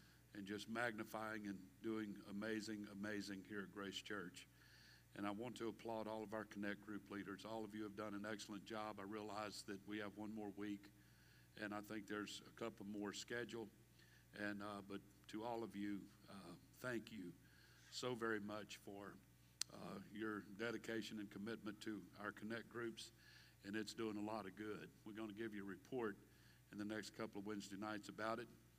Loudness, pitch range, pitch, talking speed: -51 LUFS, 100-110 Hz, 105 Hz, 190 wpm